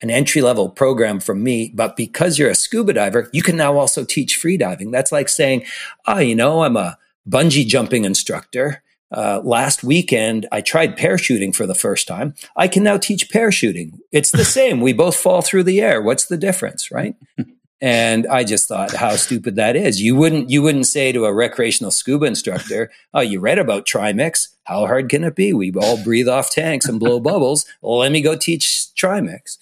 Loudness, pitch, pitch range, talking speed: -16 LUFS, 135 Hz, 120-165 Hz, 205 wpm